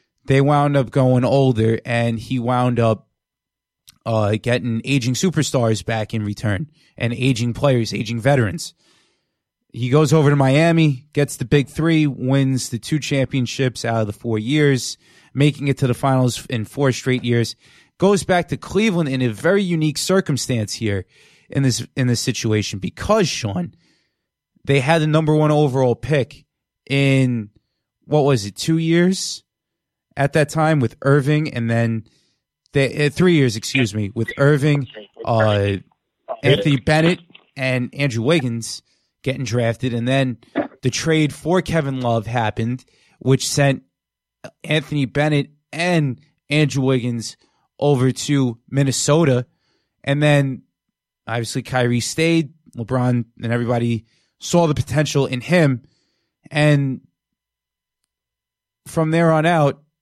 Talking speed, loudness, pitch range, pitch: 135 wpm, -19 LUFS, 120-150 Hz, 135 Hz